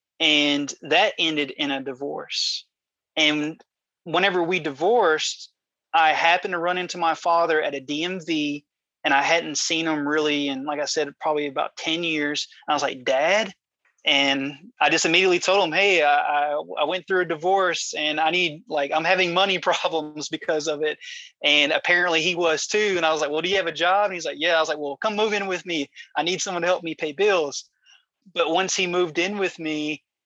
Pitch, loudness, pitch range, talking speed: 160 Hz, -22 LUFS, 150-180 Hz, 210 wpm